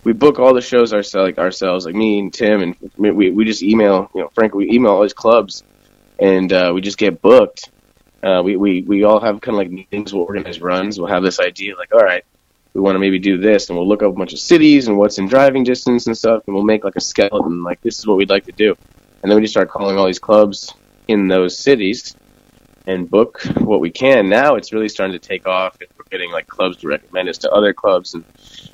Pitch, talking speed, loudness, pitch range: 100 Hz, 255 wpm, -15 LUFS, 95-110 Hz